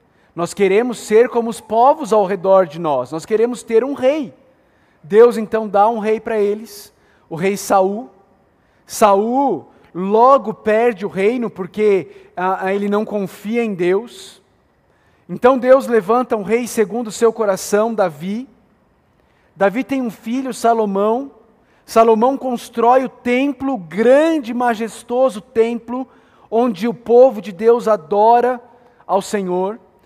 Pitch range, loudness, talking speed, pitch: 205-245 Hz, -16 LUFS, 135 wpm, 225 Hz